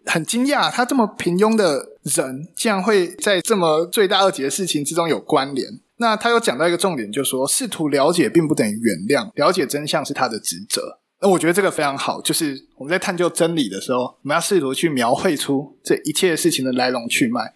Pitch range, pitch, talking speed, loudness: 140-205 Hz, 170 Hz, 340 characters per minute, -19 LUFS